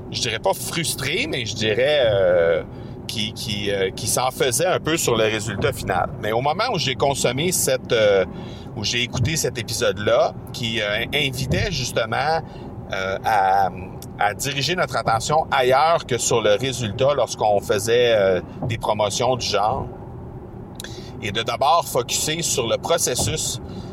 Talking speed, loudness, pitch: 155 wpm, -21 LUFS, 130 Hz